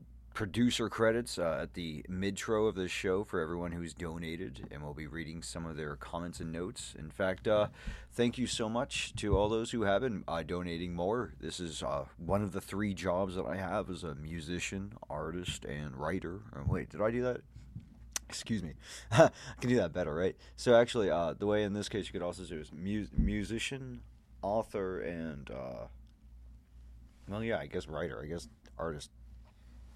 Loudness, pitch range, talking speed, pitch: -35 LUFS, 80-105 Hz, 190 wpm, 90 Hz